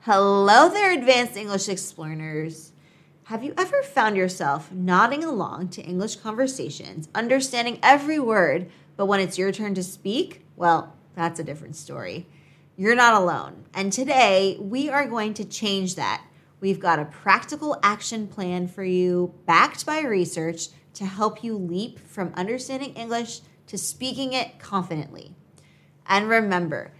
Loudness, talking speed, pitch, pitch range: -23 LUFS, 145 wpm, 195 Hz, 170-230 Hz